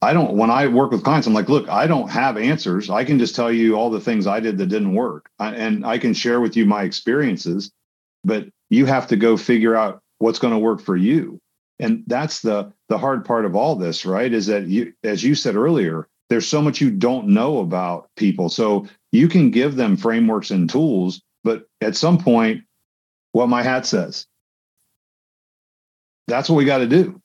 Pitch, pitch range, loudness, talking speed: 115 Hz, 105-135 Hz, -19 LUFS, 215 wpm